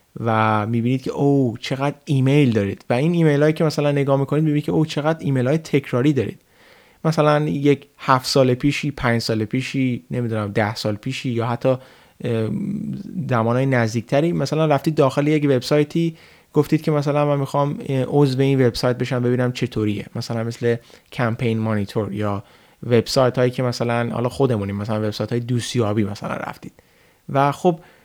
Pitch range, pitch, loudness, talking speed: 115-145 Hz, 130 Hz, -20 LUFS, 160 wpm